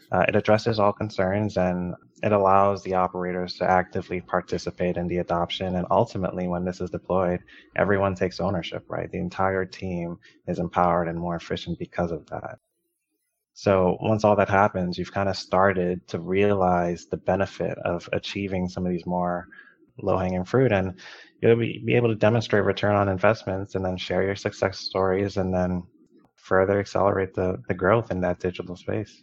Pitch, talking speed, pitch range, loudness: 95 Hz, 175 wpm, 90-100 Hz, -25 LUFS